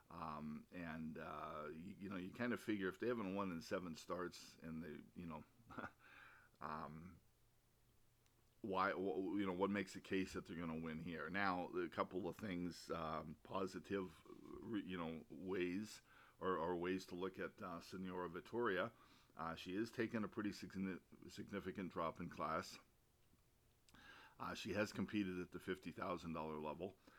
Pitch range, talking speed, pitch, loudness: 80-100 Hz, 160 wpm, 90 Hz, -47 LUFS